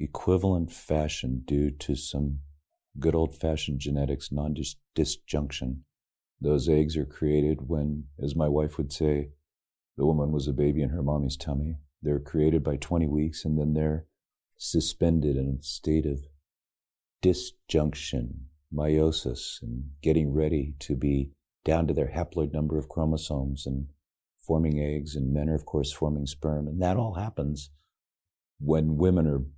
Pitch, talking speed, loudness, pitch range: 75 Hz, 150 wpm, -28 LUFS, 70-80 Hz